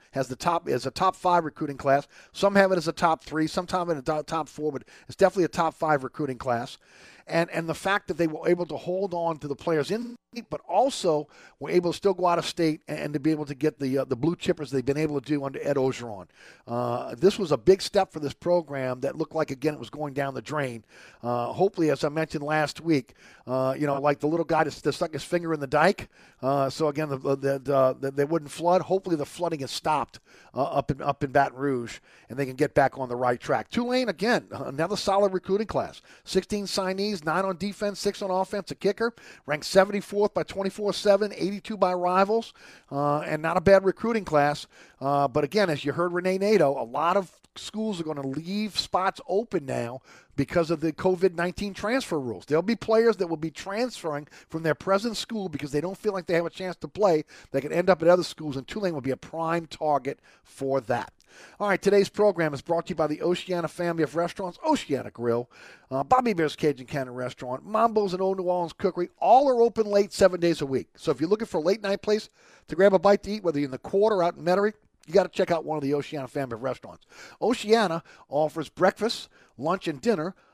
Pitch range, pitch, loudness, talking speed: 145-195 Hz, 165 Hz, -26 LUFS, 240 wpm